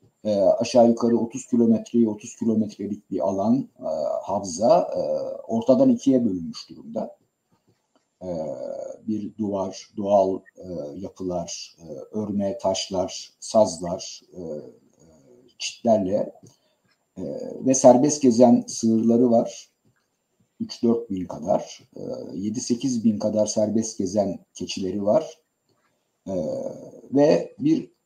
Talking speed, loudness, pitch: 105 wpm, -23 LUFS, 120 Hz